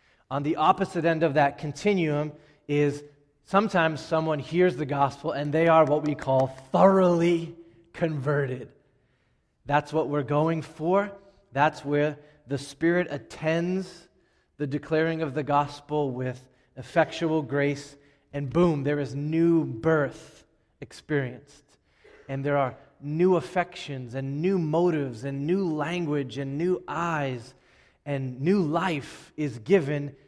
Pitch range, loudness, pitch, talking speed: 140-165 Hz, -26 LUFS, 150 Hz, 130 wpm